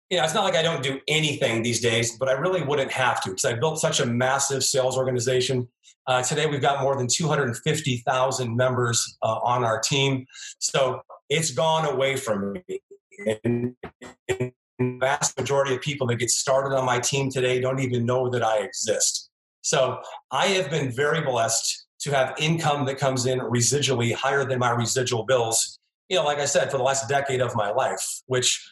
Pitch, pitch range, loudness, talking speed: 130 Hz, 125-145 Hz, -23 LUFS, 195 wpm